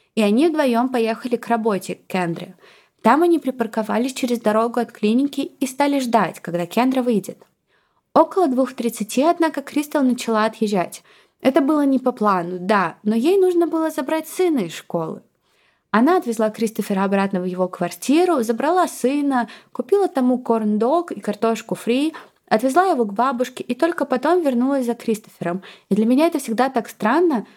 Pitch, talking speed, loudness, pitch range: 240 Hz, 160 wpm, -20 LUFS, 215-290 Hz